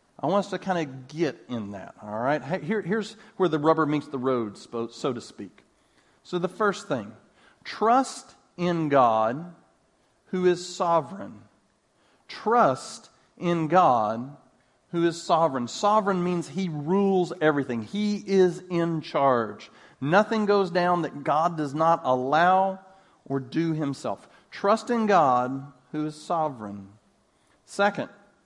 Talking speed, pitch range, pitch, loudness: 135 wpm, 140-190 Hz, 170 Hz, -25 LUFS